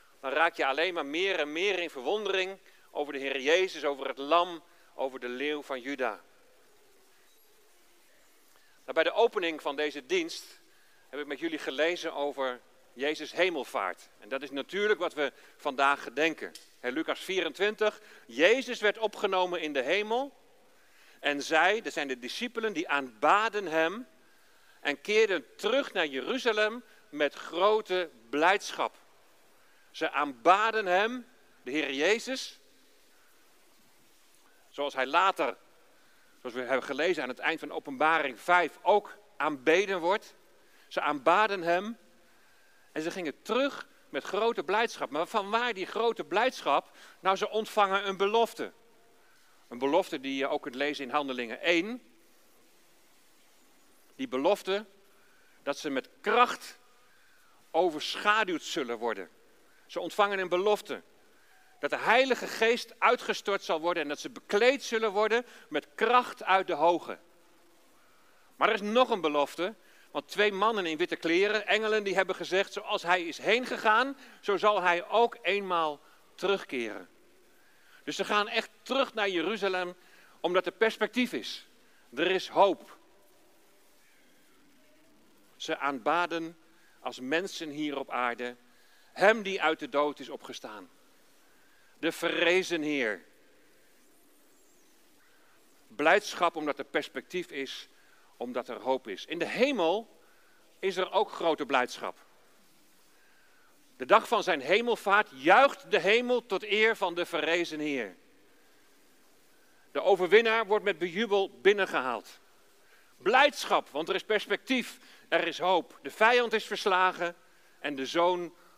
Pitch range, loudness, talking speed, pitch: 155-225 Hz, -29 LUFS, 135 wpm, 190 Hz